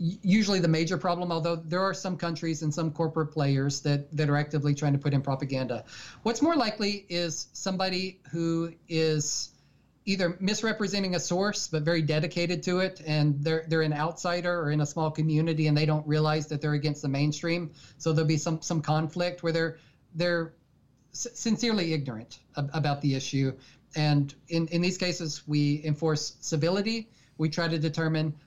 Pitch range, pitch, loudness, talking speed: 150-175 Hz, 160 Hz, -28 LUFS, 180 wpm